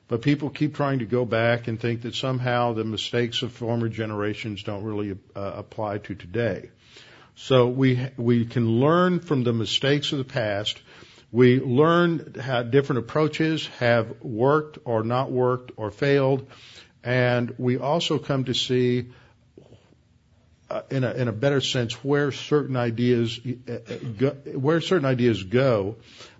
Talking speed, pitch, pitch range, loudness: 150 wpm, 125 Hz, 115-135 Hz, -24 LUFS